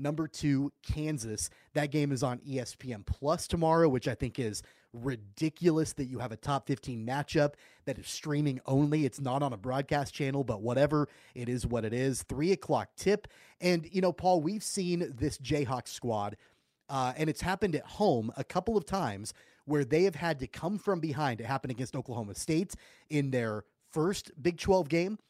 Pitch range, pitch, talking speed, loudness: 125-160 Hz, 145 Hz, 190 wpm, -32 LUFS